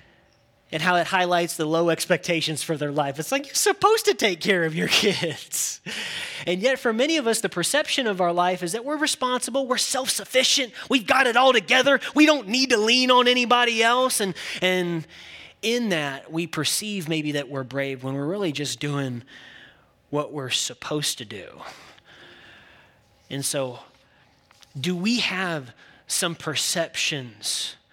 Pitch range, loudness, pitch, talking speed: 150-245 Hz, -22 LUFS, 180 Hz, 170 wpm